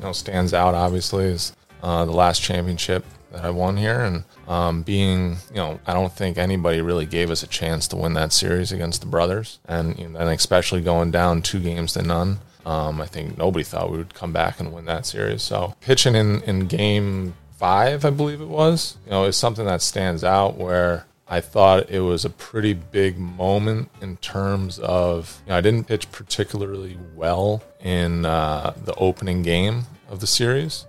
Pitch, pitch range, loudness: 90 Hz, 85-100 Hz, -22 LUFS